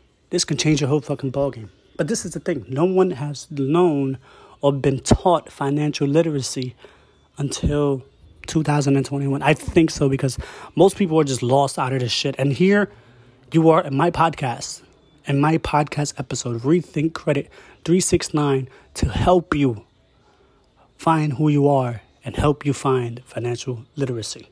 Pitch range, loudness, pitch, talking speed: 130-160 Hz, -21 LUFS, 140 Hz, 155 wpm